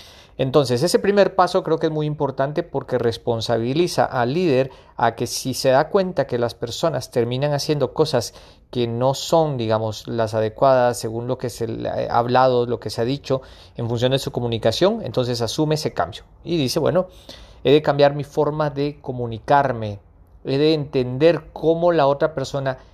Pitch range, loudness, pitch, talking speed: 120-155 Hz, -20 LUFS, 130 Hz, 180 wpm